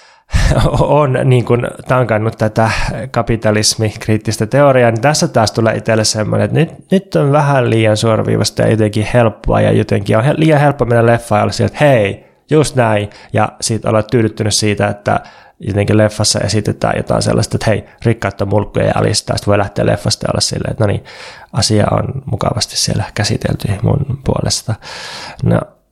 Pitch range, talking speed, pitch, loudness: 105-130 Hz, 165 wpm, 110 Hz, -13 LUFS